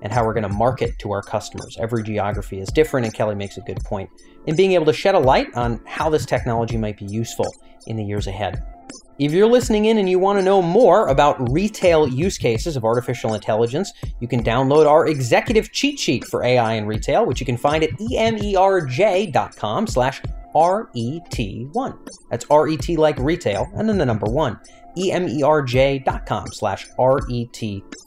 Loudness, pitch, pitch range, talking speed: -19 LUFS, 130 Hz, 115-170 Hz, 180 wpm